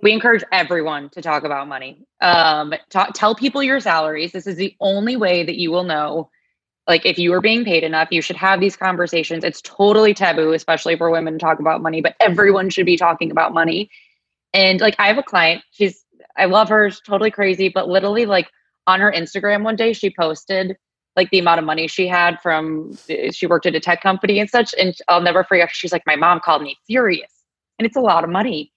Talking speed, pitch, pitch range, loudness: 225 wpm, 180 Hz, 165-205 Hz, -16 LUFS